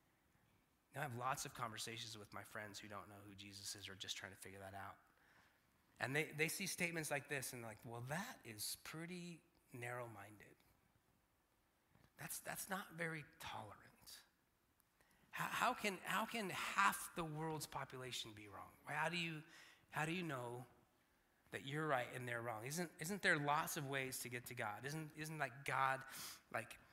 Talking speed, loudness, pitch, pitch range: 180 wpm, -45 LUFS, 135 Hz, 115-160 Hz